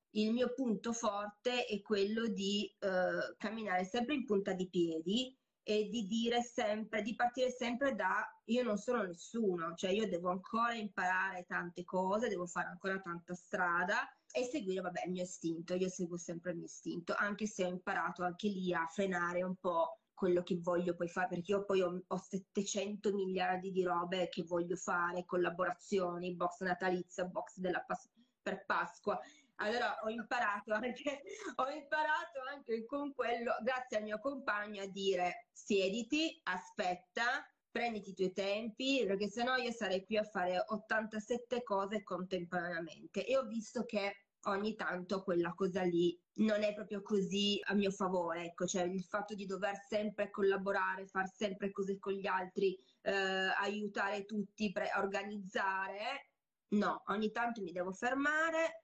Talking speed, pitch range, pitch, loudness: 160 wpm, 185-220 Hz, 200 Hz, -38 LUFS